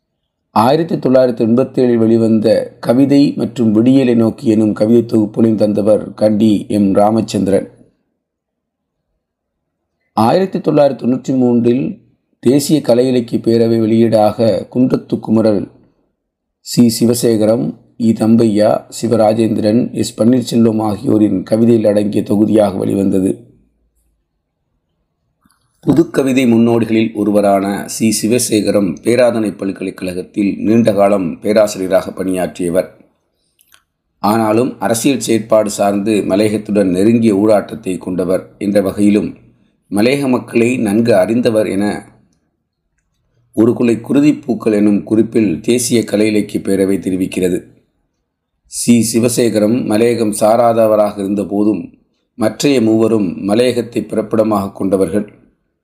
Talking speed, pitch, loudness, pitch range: 85 wpm, 110 Hz, -13 LUFS, 105-120 Hz